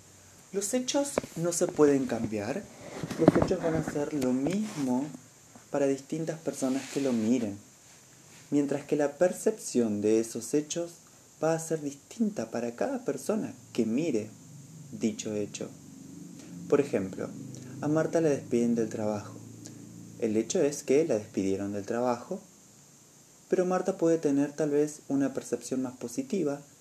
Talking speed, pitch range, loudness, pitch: 140 wpm, 120-160 Hz, -30 LUFS, 140 Hz